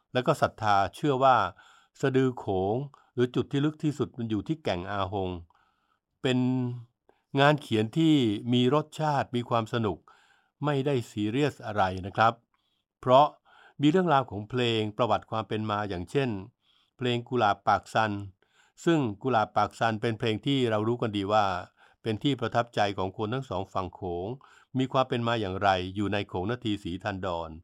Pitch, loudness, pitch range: 115 Hz, -28 LUFS, 100-130 Hz